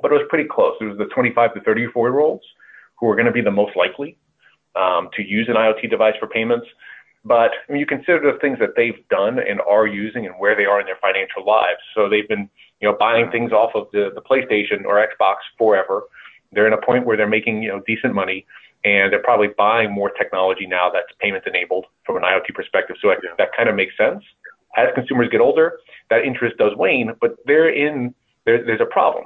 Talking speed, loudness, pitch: 230 wpm, -18 LUFS, 120 Hz